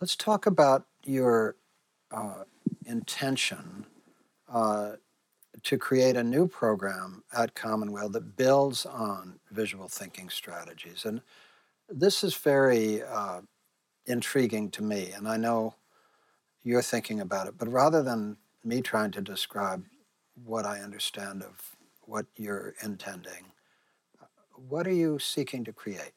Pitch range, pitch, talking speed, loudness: 105-135 Hz, 115 Hz, 125 wpm, -29 LUFS